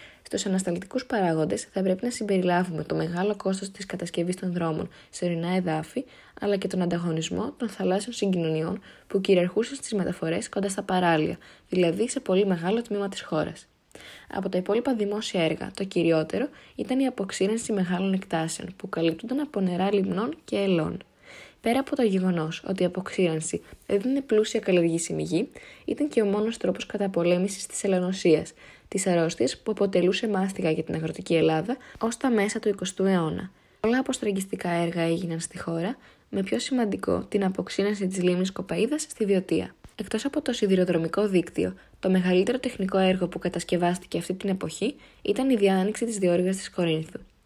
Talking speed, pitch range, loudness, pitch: 160 wpm, 175-215 Hz, -27 LUFS, 190 Hz